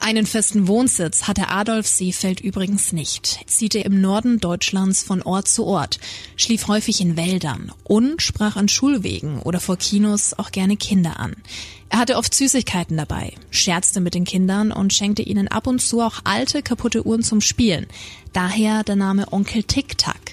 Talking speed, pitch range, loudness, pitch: 170 wpm, 180-220 Hz, -19 LUFS, 200 Hz